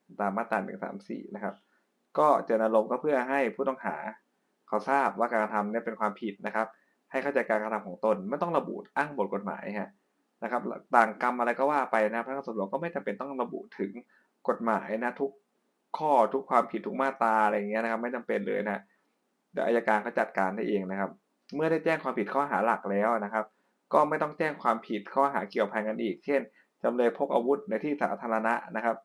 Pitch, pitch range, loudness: 115 Hz, 110-135 Hz, -29 LUFS